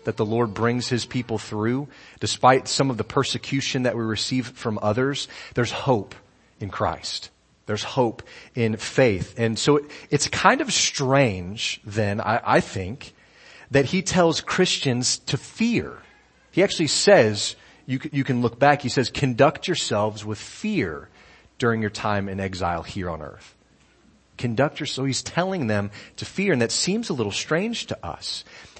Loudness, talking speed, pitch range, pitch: -23 LUFS, 165 wpm, 110-140 Hz, 125 Hz